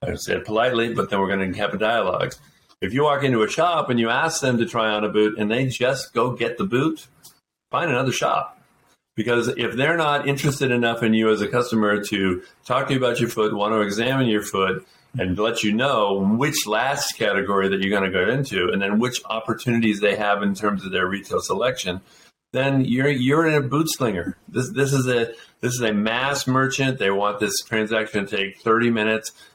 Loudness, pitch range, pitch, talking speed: -21 LUFS, 105-130 Hz, 110 Hz, 220 wpm